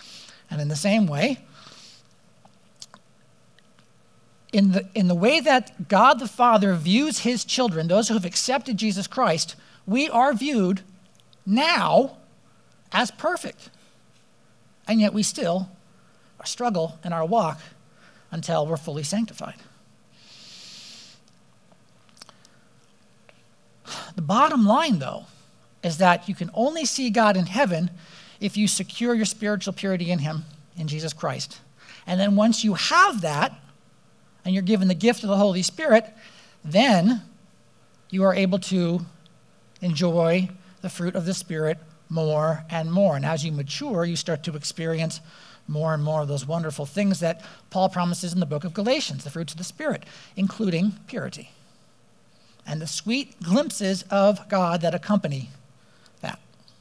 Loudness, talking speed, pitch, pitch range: -23 LUFS, 140 wpm, 190 Hz, 165-215 Hz